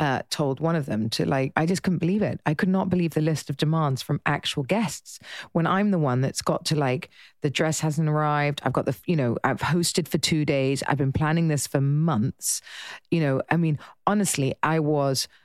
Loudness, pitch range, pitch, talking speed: -24 LUFS, 140-165 Hz, 155 Hz, 225 wpm